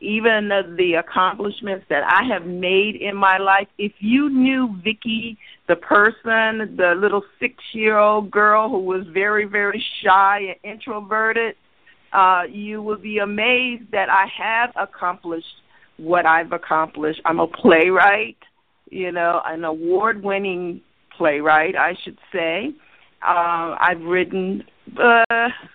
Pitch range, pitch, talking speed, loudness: 180-220 Hz, 200 Hz, 135 wpm, -18 LUFS